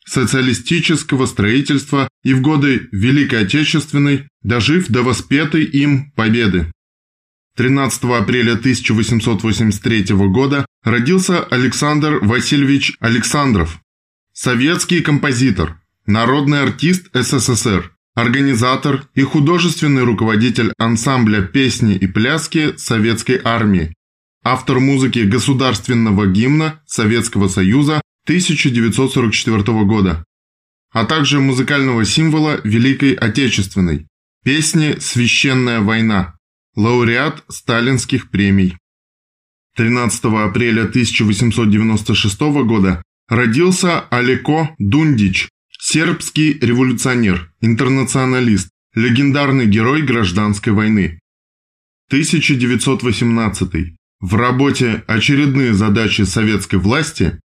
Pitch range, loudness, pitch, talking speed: 105-140 Hz, -14 LUFS, 120 Hz, 80 wpm